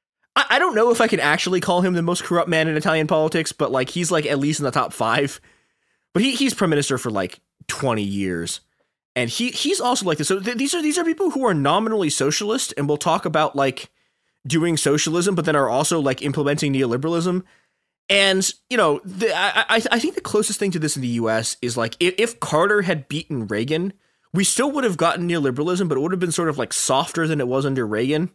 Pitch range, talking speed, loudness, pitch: 140-200 Hz, 230 wpm, -20 LUFS, 165 Hz